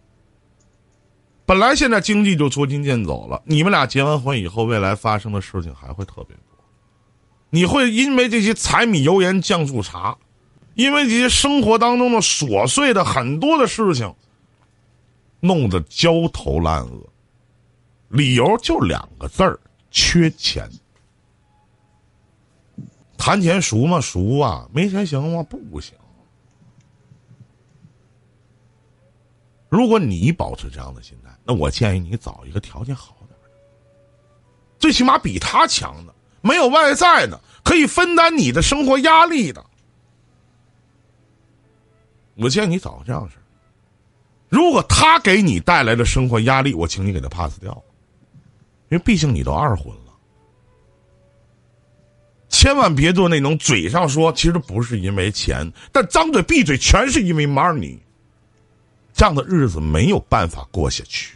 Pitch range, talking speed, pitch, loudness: 110-170 Hz, 215 characters per minute, 120 Hz, -16 LUFS